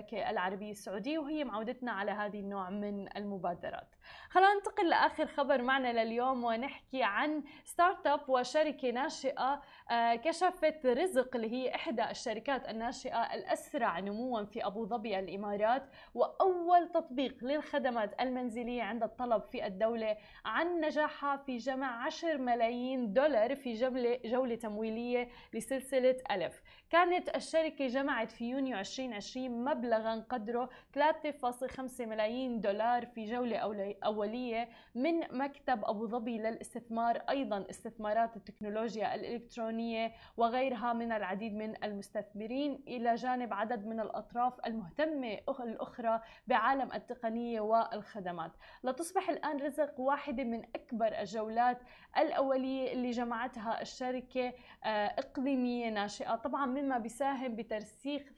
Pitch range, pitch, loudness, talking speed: 225-275 Hz, 245 Hz, -35 LUFS, 115 wpm